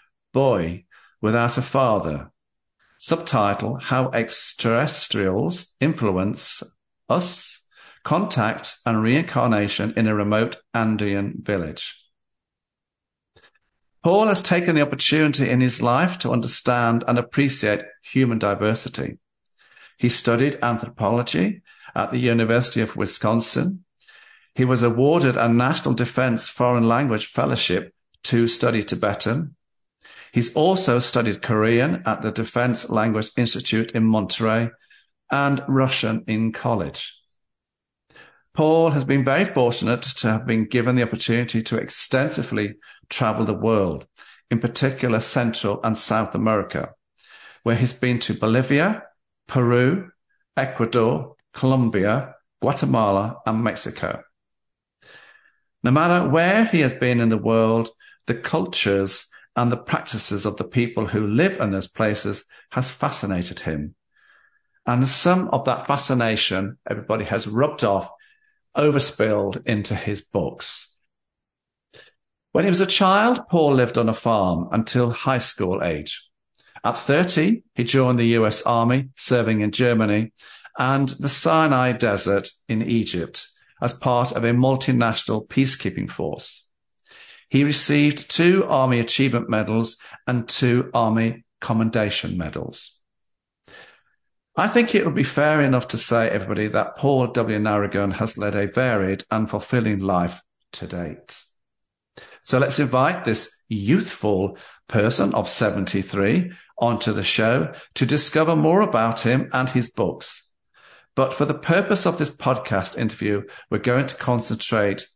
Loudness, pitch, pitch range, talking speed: -21 LUFS, 120 Hz, 110-135 Hz, 125 wpm